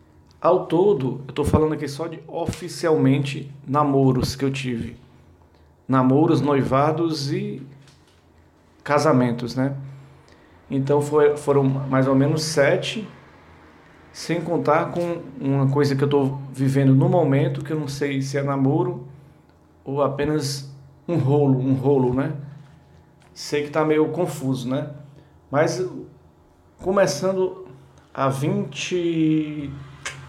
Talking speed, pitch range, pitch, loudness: 120 wpm, 135-155 Hz, 140 Hz, -21 LUFS